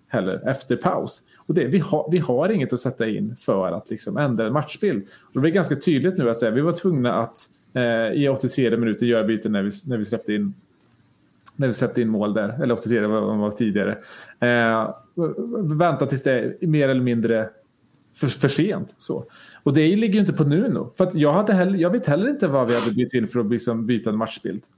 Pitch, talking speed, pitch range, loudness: 125 Hz, 230 wpm, 115-155 Hz, -22 LUFS